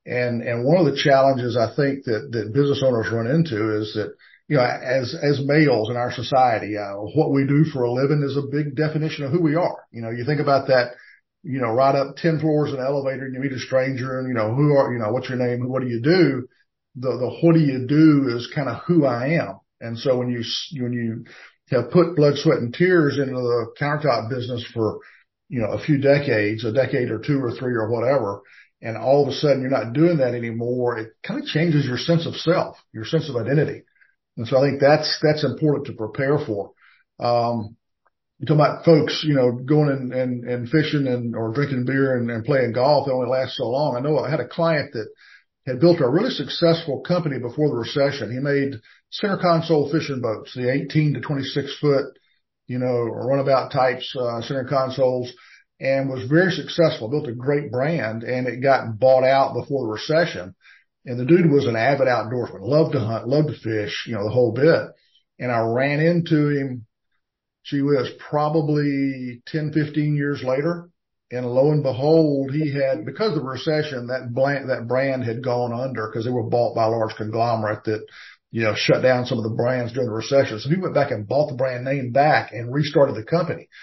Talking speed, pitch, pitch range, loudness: 215 wpm, 135 Hz, 120-145 Hz, -21 LUFS